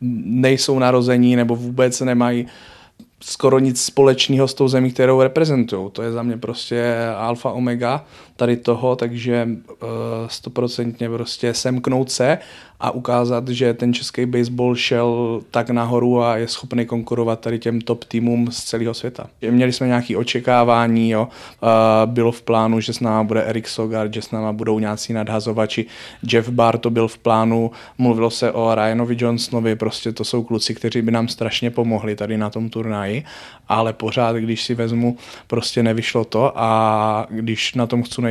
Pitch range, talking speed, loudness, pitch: 115-120 Hz, 170 wpm, -19 LUFS, 120 Hz